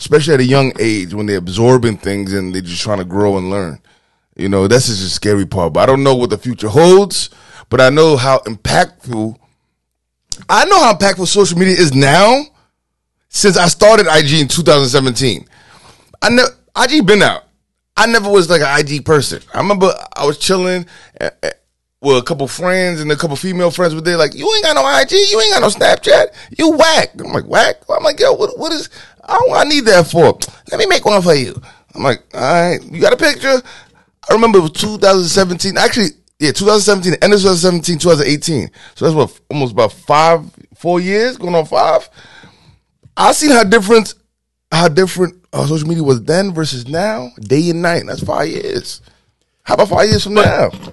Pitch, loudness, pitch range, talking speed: 165 Hz, -12 LUFS, 130-195 Hz, 200 wpm